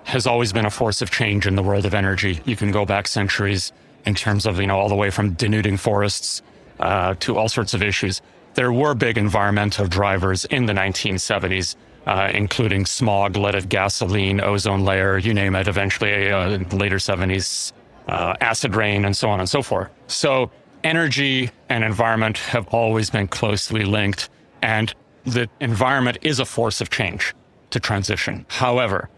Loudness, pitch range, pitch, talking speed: -20 LUFS, 100-115 Hz, 105 Hz, 180 wpm